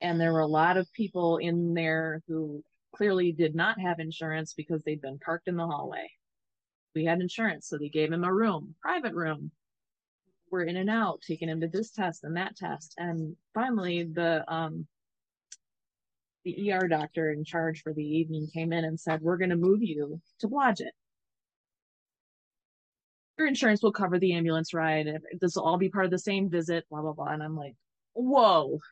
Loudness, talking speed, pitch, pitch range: -29 LUFS, 190 wpm, 165 Hz, 155-185 Hz